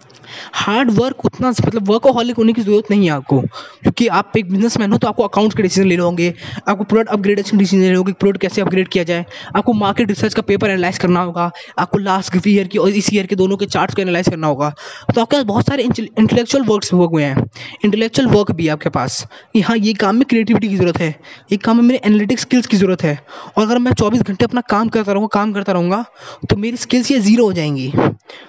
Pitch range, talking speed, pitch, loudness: 180-225 Hz, 245 wpm, 205 Hz, -15 LUFS